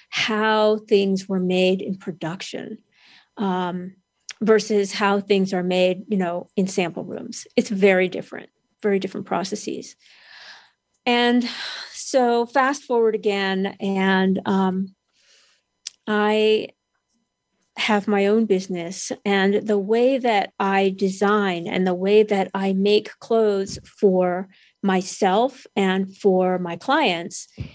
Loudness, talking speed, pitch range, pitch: -21 LUFS, 115 wpm, 190-215 Hz, 200 Hz